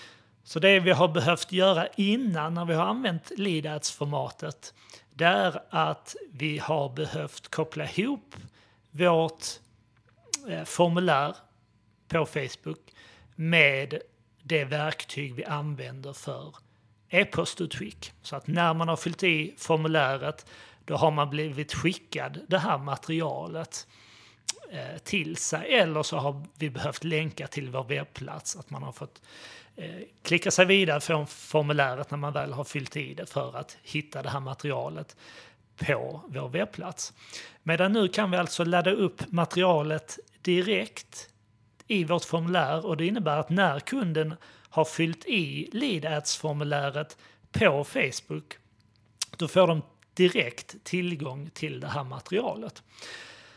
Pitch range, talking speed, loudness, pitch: 140-170 Hz, 130 wpm, -28 LUFS, 155 Hz